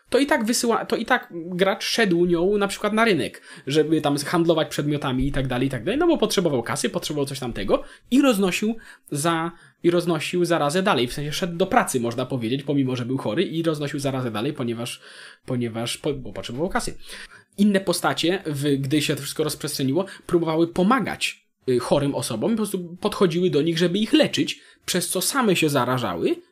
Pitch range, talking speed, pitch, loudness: 140-195 Hz, 175 wpm, 170 Hz, -23 LUFS